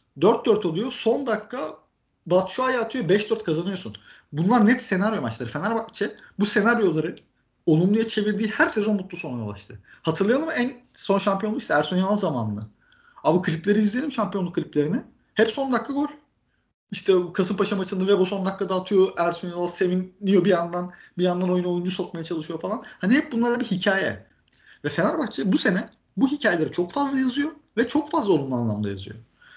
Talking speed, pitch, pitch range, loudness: 165 wpm, 195 Hz, 175-230 Hz, -24 LUFS